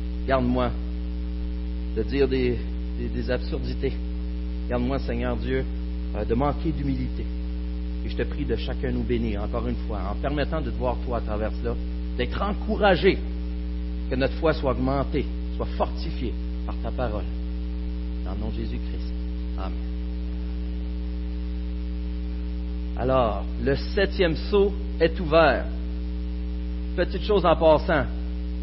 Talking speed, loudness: 130 wpm, -27 LUFS